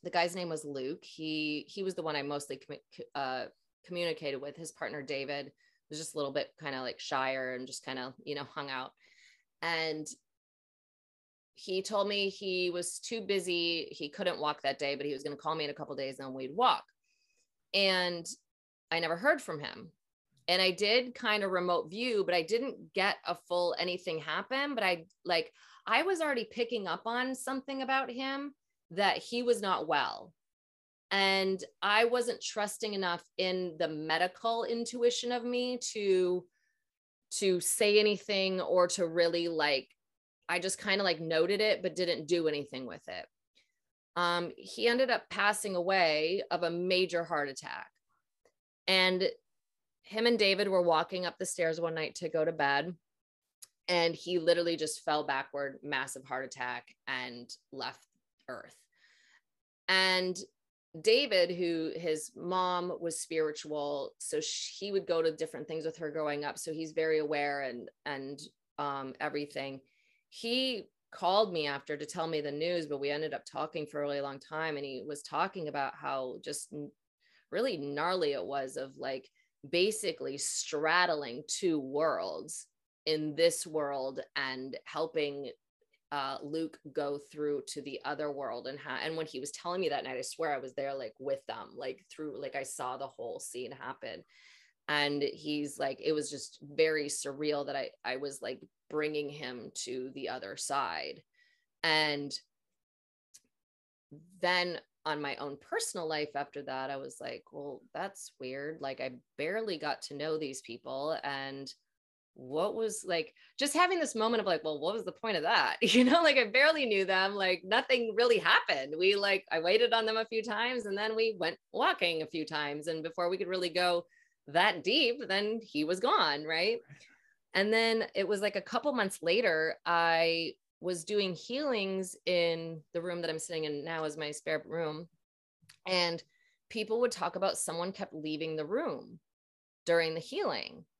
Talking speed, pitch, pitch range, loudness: 175 wpm, 170 Hz, 150-205 Hz, -33 LUFS